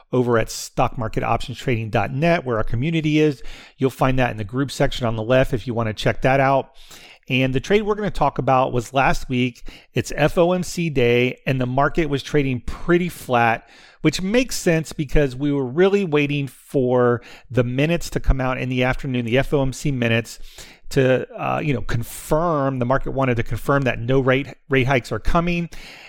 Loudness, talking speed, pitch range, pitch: -21 LUFS, 190 wpm, 125-150 Hz, 135 Hz